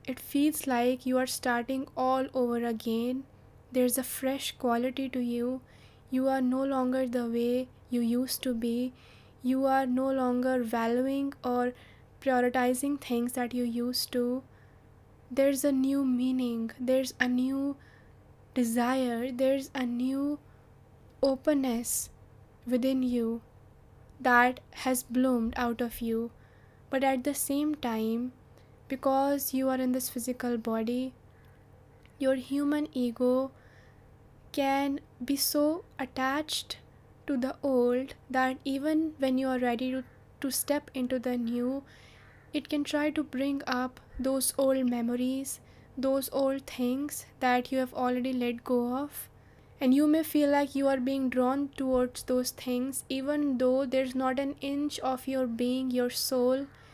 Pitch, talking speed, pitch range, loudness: 260 Hz, 140 wpm, 245-270 Hz, -30 LUFS